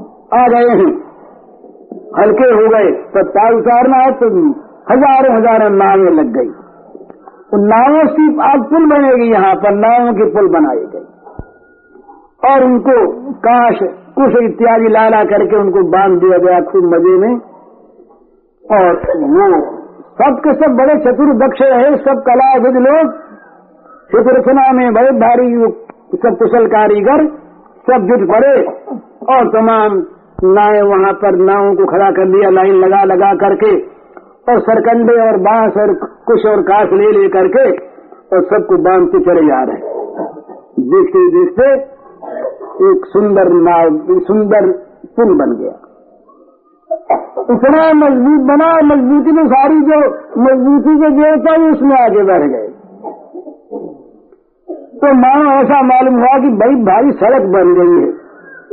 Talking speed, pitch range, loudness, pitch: 125 wpm, 215-320 Hz, -9 LUFS, 265 Hz